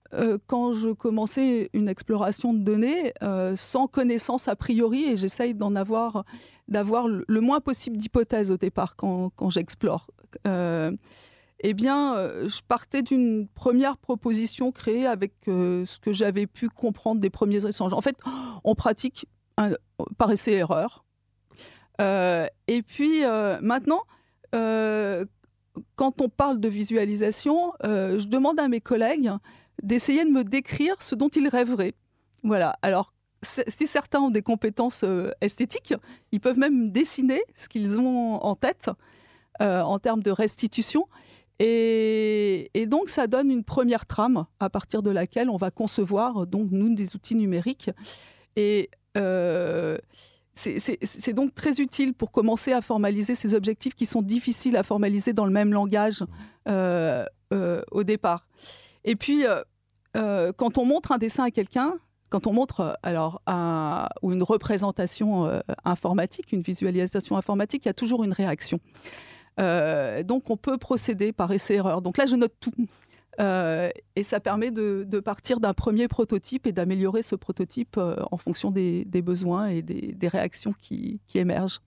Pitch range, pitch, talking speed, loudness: 195-250 Hz, 220 Hz, 160 wpm, -25 LUFS